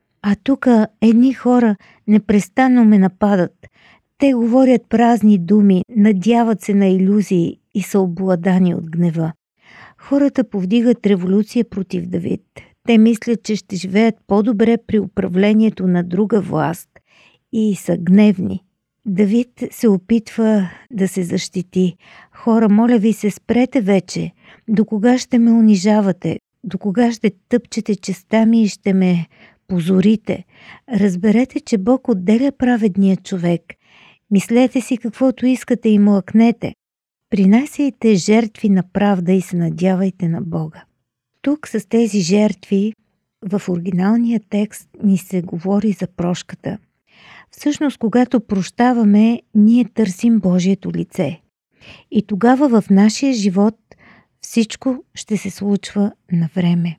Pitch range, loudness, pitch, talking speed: 190-230 Hz, -16 LUFS, 210 Hz, 125 wpm